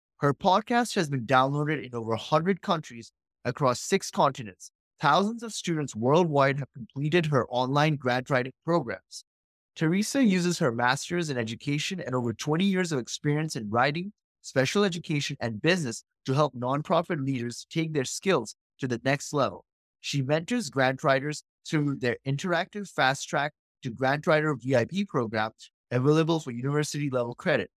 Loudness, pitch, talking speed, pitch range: -27 LUFS, 145 Hz, 155 wpm, 130-170 Hz